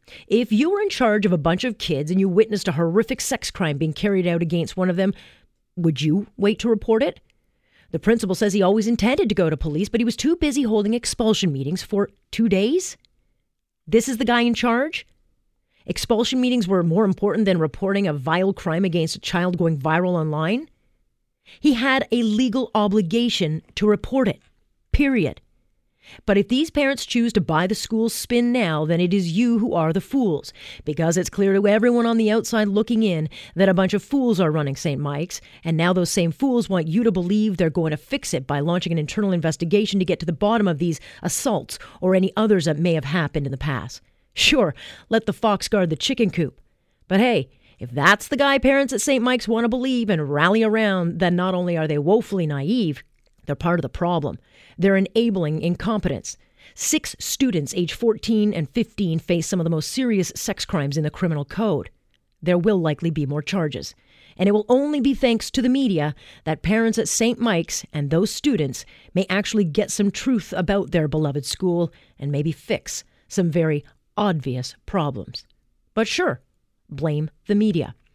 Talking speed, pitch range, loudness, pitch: 200 wpm, 165-225 Hz, -21 LUFS, 195 Hz